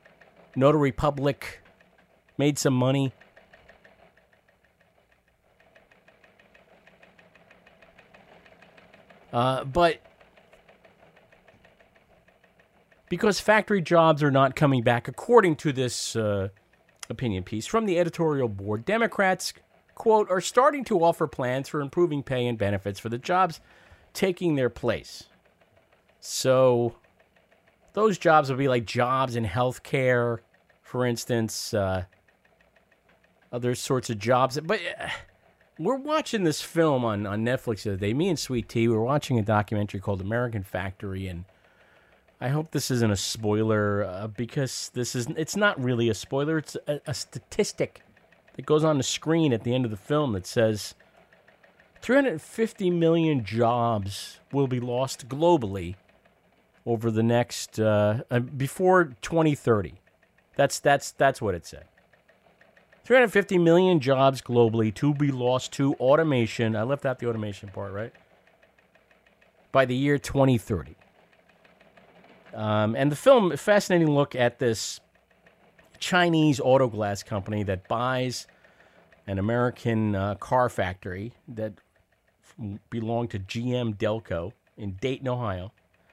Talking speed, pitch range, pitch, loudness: 125 wpm, 110-150 Hz, 125 Hz, -25 LUFS